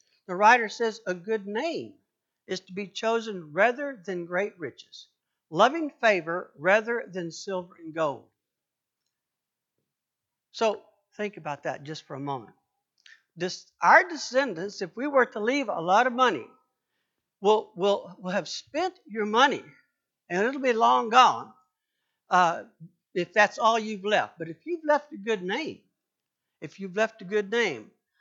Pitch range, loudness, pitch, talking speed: 180-235 Hz, -26 LUFS, 210 Hz, 155 wpm